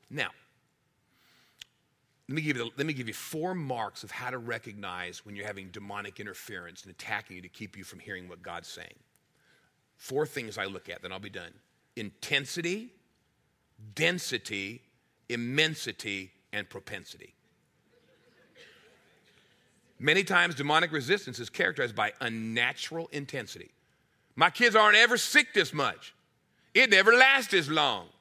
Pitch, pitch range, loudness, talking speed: 130 Hz, 105-165 Hz, -27 LUFS, 140 wpm